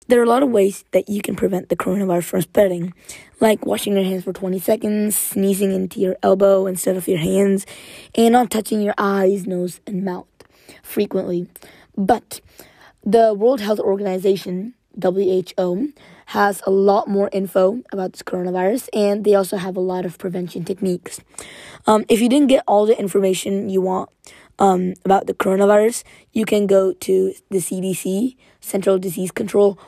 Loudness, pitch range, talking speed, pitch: -19 LUFS, 185-210 Hz, 170 wpm, 195 Hz